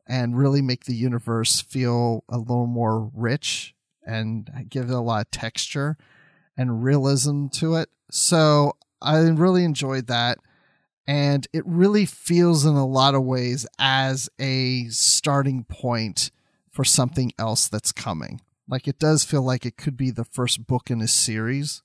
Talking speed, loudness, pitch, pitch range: 160 wpm, -22 LUFS, 130 Hz, 120-145 Hz